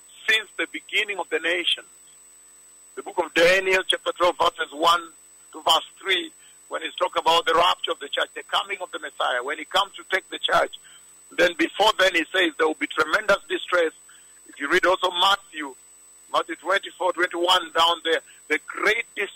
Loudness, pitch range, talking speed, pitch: -22 LUFS, 160-190 Hz, 180 wpm, 175 Hz